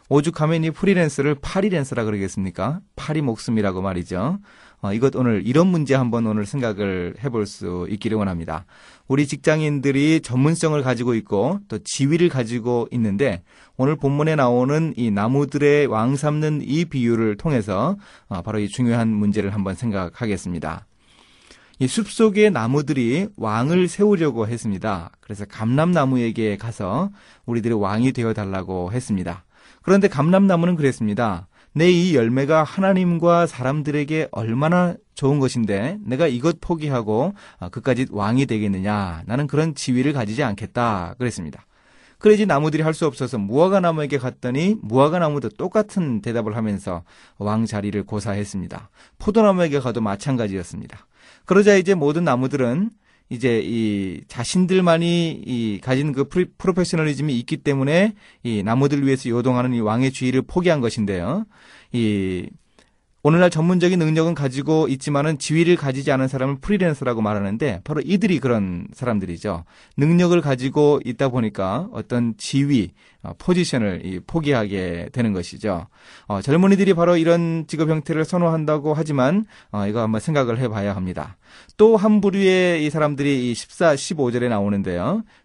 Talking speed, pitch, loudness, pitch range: 345 characters per minute, 135 Hz, -20 LUFS, 110-160 Hz